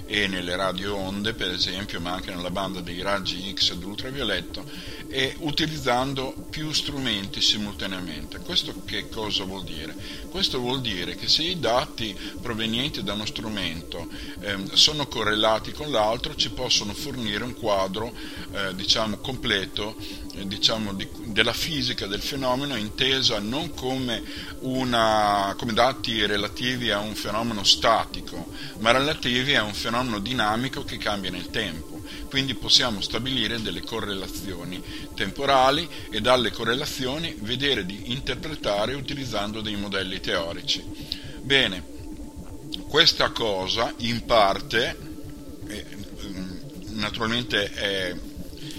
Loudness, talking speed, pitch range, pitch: -24 LUFS, 120 wpm, 100-130 Hz, 110 Hz